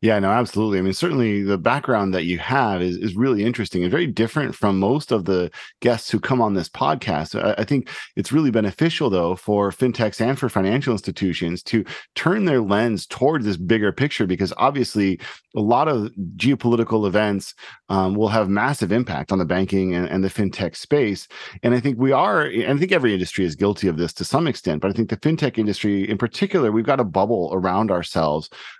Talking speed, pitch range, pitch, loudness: 210 wpm, 95-120 Hz, 105 Hz, -21 LUFS